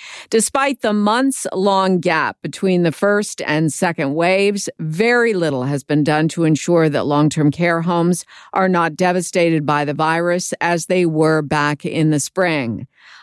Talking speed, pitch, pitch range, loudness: 165 wpm, 170 Hz, 155-190 Hz, -17 LUFS